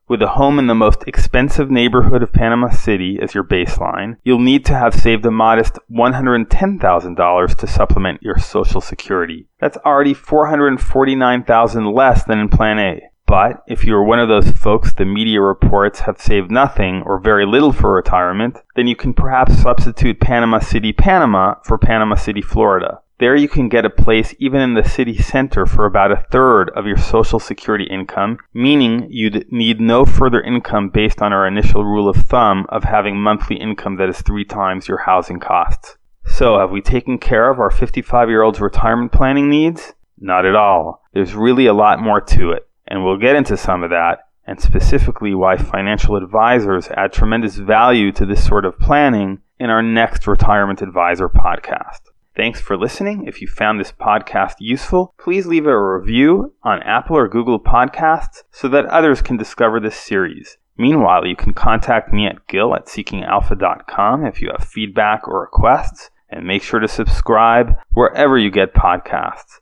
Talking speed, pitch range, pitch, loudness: 185 wpm, 100-125 Hz, 110 Hz, -15 LUFS